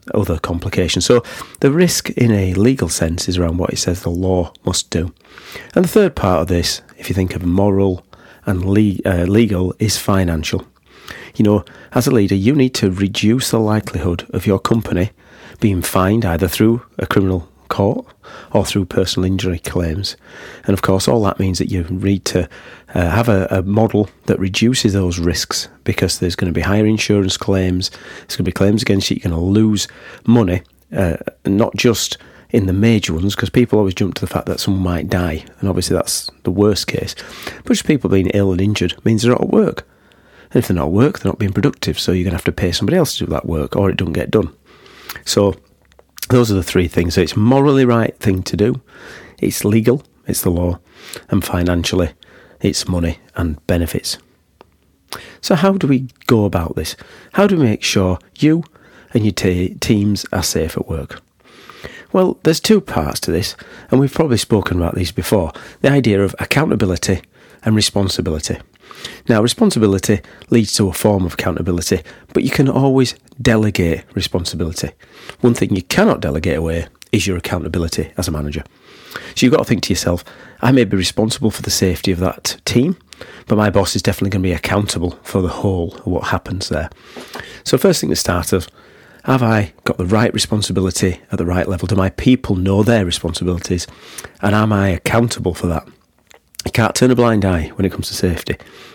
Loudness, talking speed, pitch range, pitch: -16 LUFS, 195 wpm, 90-110 Hz, 95 Hz